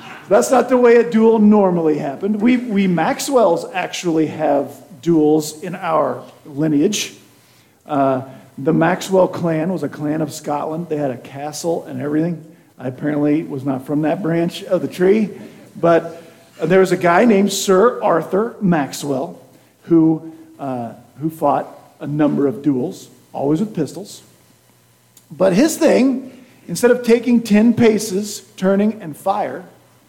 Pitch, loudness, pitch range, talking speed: 165 Hz, -17 LUFS, 150-200 Hz, 150 wpm